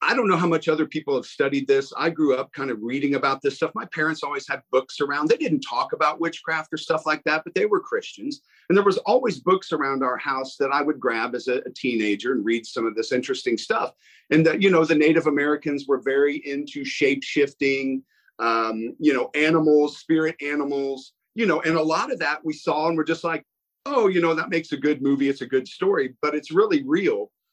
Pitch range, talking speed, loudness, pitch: 140-165 Hz, 235 wpm, -23 LUFS, 150 Hz